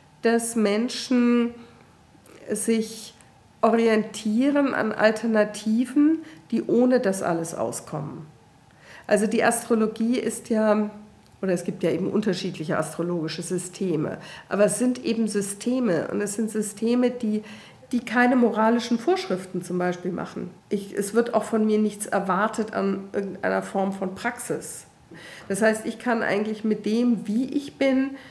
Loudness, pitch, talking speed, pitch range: -24 LUFS, 215 Hz, 135 wpm, 195-235 Hz